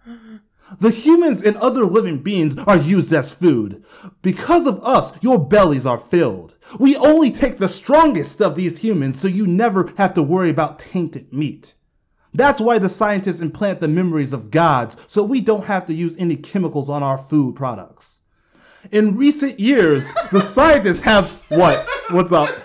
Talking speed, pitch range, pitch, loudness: 170 wpm, 160-225 Hz, 190 Hz, -16 LUFS